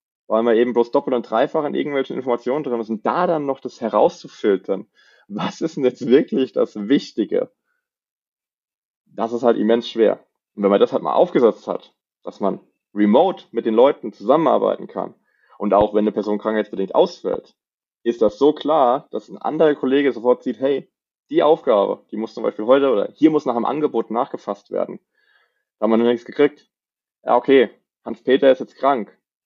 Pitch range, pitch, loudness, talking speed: 115-140 Hz, 120 Hz, -19 LUFS, 185 wpm